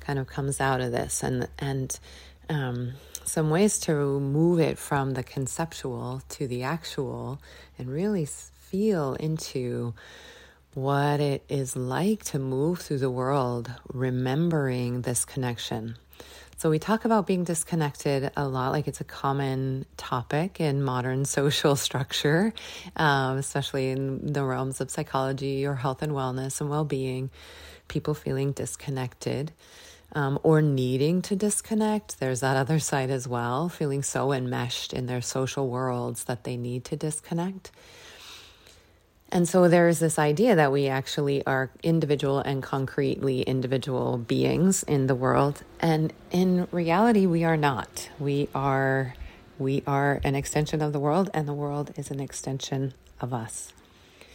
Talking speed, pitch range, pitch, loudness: 145 wpm, 130-155 Hz, 140 Hz, -27 LUFS